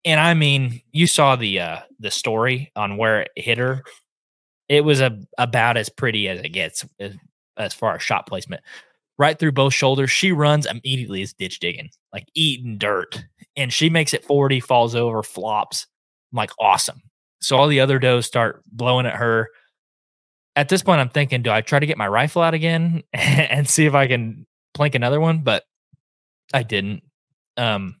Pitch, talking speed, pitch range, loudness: 130 Hz, 185 wpm, 115-145 Hz, -19 LUFS